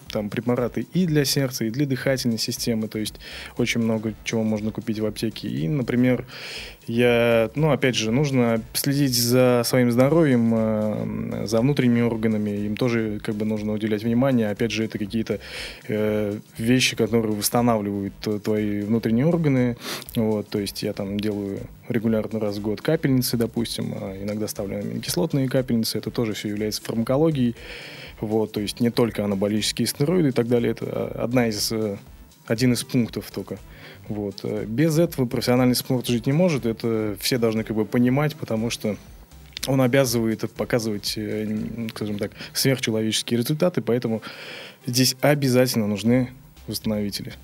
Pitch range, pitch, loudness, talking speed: 110-125 Hz, 115 Hz, -23 LUFS, 150 wpm